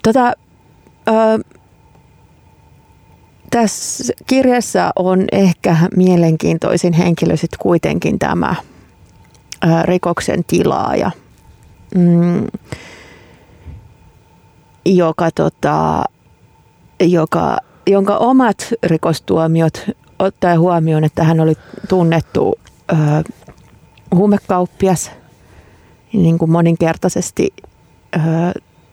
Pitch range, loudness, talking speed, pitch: 165-200 Hz, -15 LUFS, 65 wpm, 175 Hz